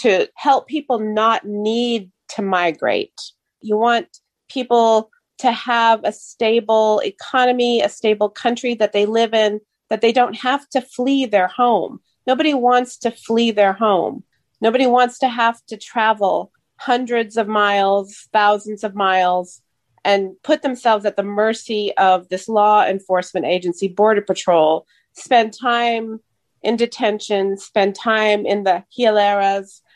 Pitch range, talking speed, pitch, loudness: 200-240 Hz, 140 wpm, 220 Hz, -17 LUFS